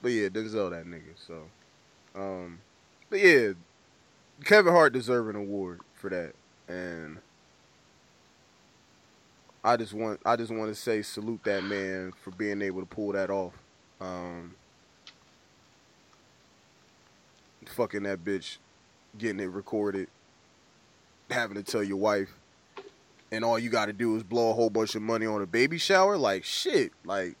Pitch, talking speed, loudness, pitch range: 105 Hz, 145 wpm, -28 LUFS, 95-115 Hz